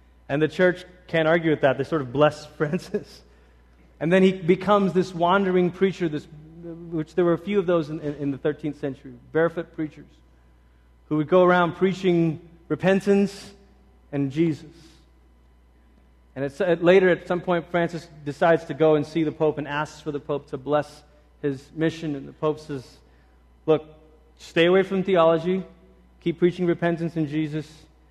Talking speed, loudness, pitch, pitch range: 175 wpm, -23 LUFS, 155 Hz, 140-175 Hz